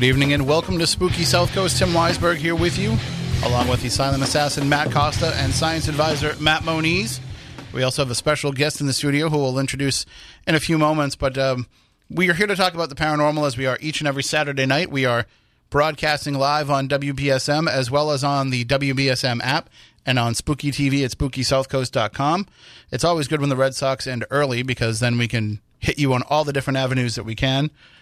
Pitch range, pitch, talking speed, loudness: 130-150 Hz, 140 Hz, 215 wpm, -20 LUFS